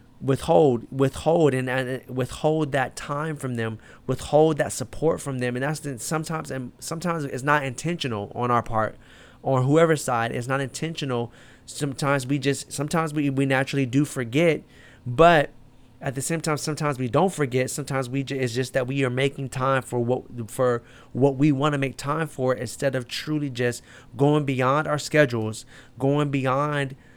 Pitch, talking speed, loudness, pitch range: 135 Hz, 175 wpm, -24 LUFS, 125-150 Hz